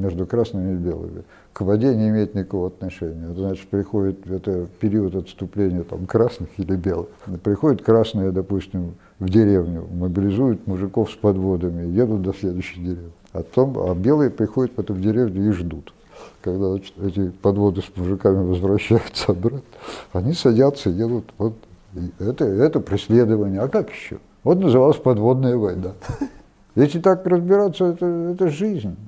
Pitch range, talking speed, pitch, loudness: 95-120 Hz, 150 wpm, 100 Hz, -21 LUFS